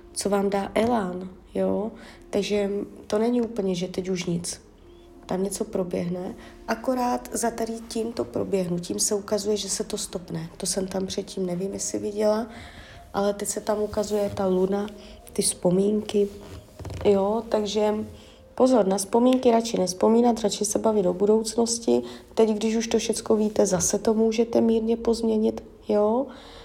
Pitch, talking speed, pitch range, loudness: 205 Hz, 160 wpm, 190-225 Hz, -25 LUFS